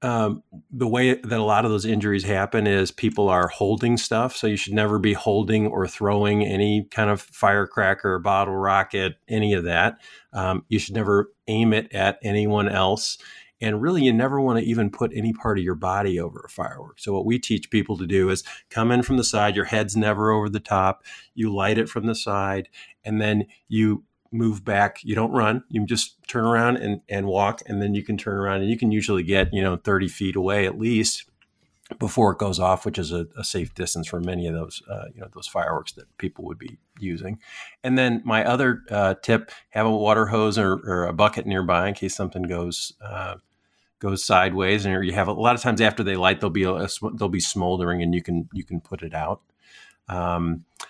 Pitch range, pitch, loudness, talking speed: 95-110 Hz, 105 Hz, -23 LUFS, 220 wpm